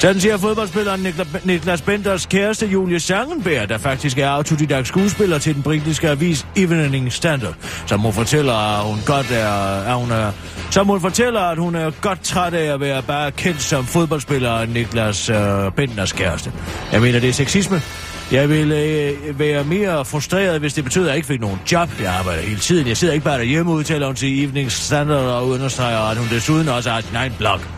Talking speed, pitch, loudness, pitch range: 200 wpm, 145 Hz, -18 LUFS, 115-170 Hz